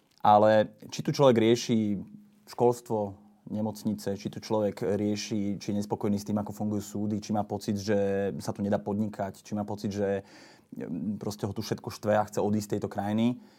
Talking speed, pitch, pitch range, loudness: 185 wpm, 105 Hz, 105-110 Hz, -29 LUFS